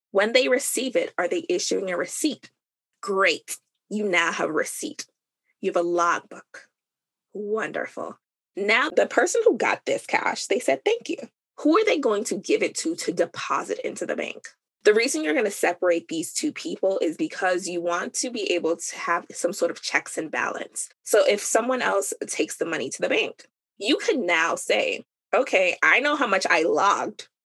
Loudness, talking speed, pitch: -24 LUFS, 195 wpm, 300 Hz